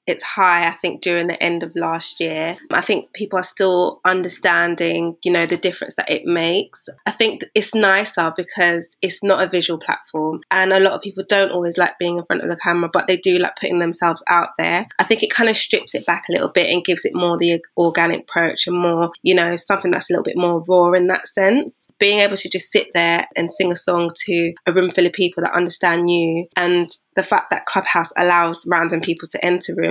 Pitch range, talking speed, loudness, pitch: 170-185 Hz, 235 wpm, -17 LUFS, 175 Hz